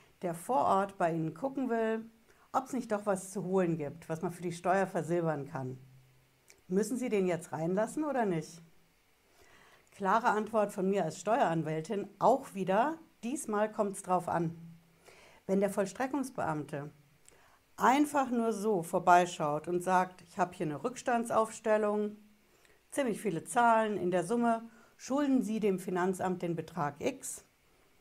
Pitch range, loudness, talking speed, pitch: 170-225 Hz, -32 LUFS, 150 wpm, 190 Hz